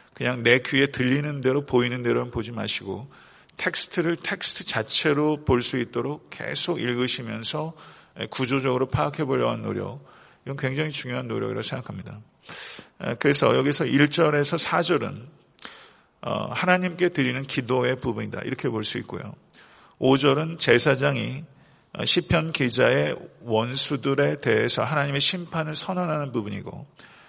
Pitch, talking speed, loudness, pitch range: 135 Hz, 310 characters per minute, -24 LUFS, 125-155 Hz